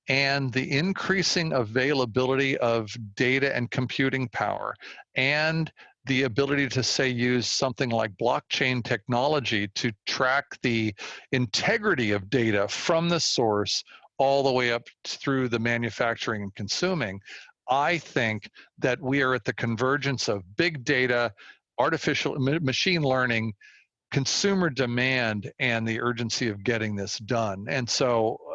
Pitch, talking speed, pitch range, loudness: 130 Hz, 130 wpm, 115-140 Hz, -26 LUFS